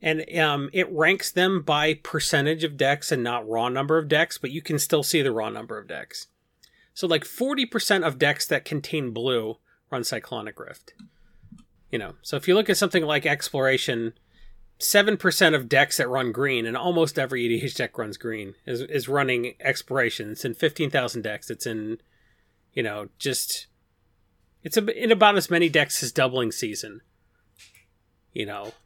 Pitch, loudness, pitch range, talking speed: 145 Hz, -24 LUFS, 115-165 Hz, 175 wpm